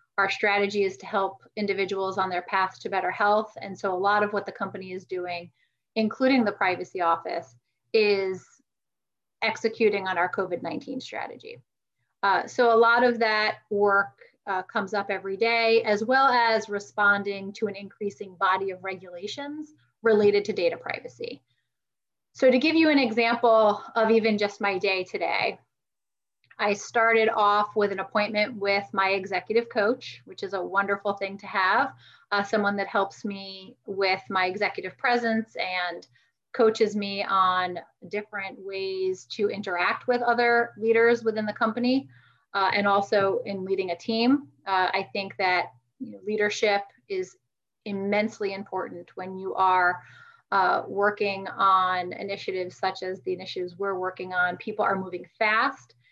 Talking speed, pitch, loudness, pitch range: 155 wpm, 200 Hz, -25 LUFS, 190-225 Hz